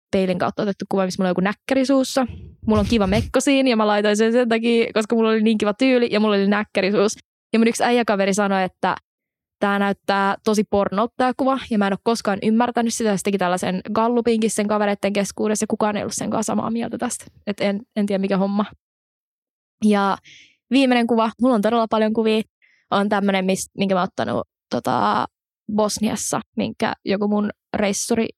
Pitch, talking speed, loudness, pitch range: 215 Hz, 190 wpm, -20 LUFS, 200-230 Hz